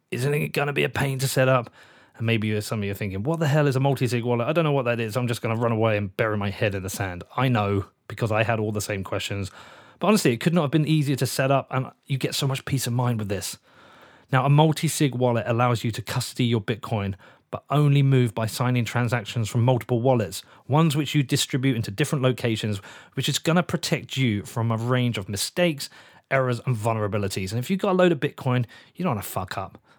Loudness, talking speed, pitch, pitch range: -24 LUFS, 260 wpm, 125 Hz, 110-140 Hz